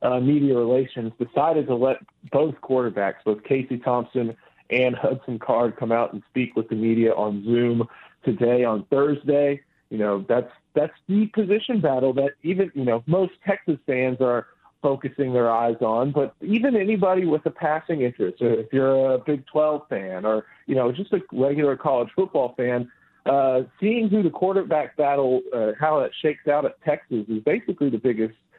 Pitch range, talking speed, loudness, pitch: 120-155 Hz, 175 wpm, -23 LUFS, 130 Hz